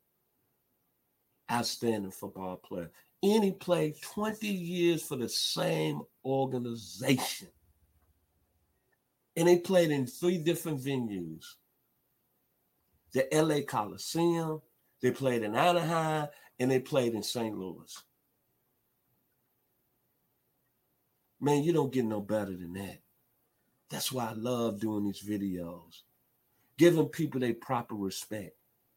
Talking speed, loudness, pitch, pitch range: 110 wpm, -31 LUFS, 125 Hz, 100-155 Hz